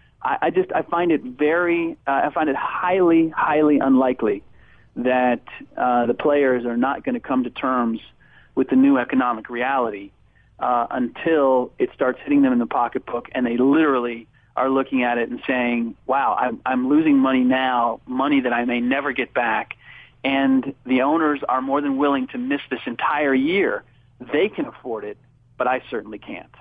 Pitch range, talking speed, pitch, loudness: 125-160 Hz, 180 wpm, 130 Hz, -21 LUFS